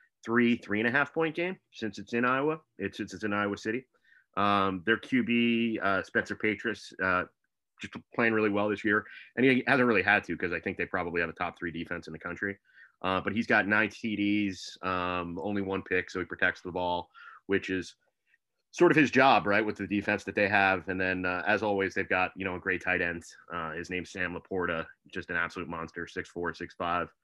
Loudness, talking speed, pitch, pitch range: -29 LUFS, 230 wpm, 100 Hz, 90-110 Hz